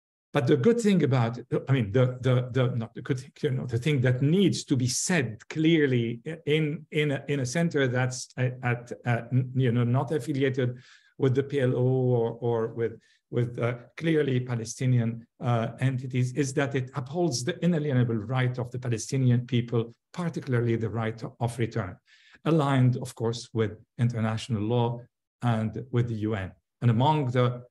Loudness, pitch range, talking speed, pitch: -27 LUFS, 115-140 Hz, 170 wpm, 125 Hz